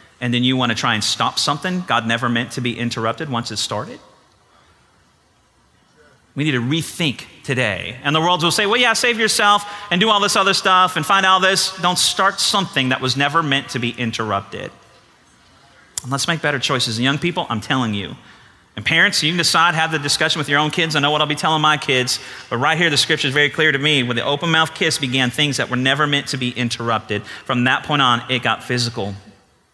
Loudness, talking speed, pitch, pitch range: -17 LUFS, 230 wpm, 140 Hz, 120-170 Hz